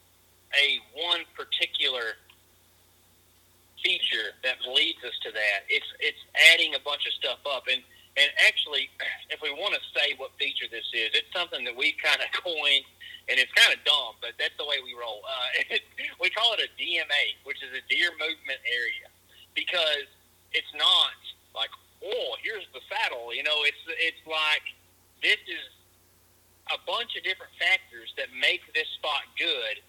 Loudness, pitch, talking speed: -25 LUFS, 165 Hz, 170 wpm